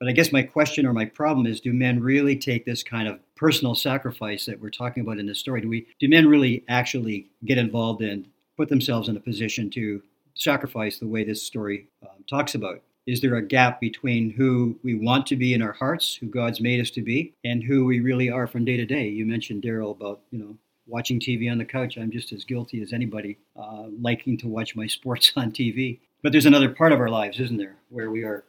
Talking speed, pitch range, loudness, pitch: 240 wpm, 110-130 Hz, -23 LUFS, 120 Hz